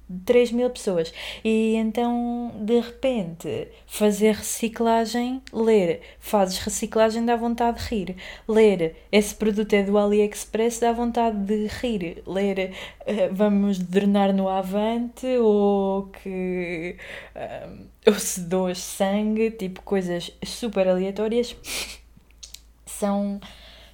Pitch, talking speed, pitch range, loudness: 210 Hz, 105 wpm, 195-230 Hz, -23 LUFS